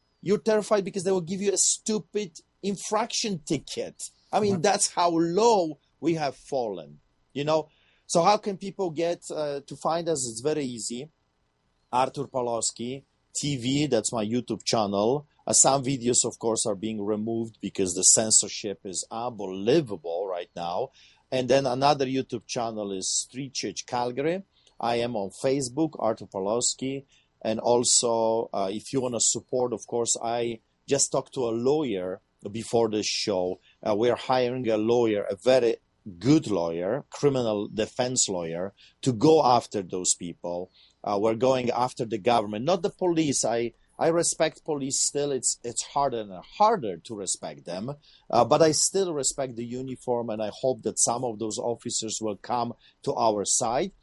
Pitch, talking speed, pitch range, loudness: 125 Hz, 165 wpm, 110-150 Hz, -26 LUFS